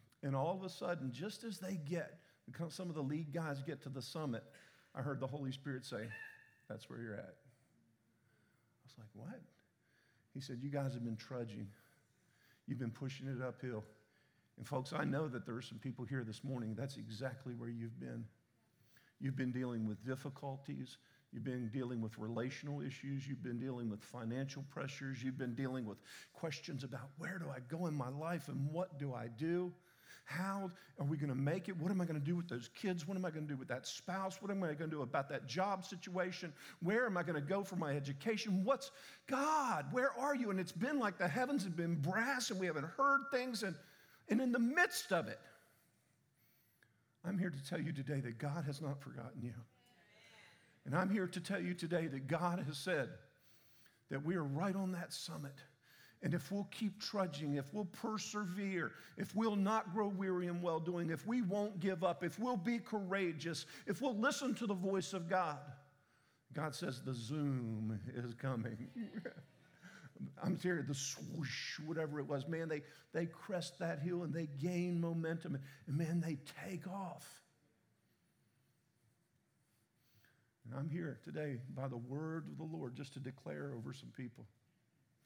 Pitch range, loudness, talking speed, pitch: 130-185 Hz, -42 LUFS, 190 wpm, 150 Hz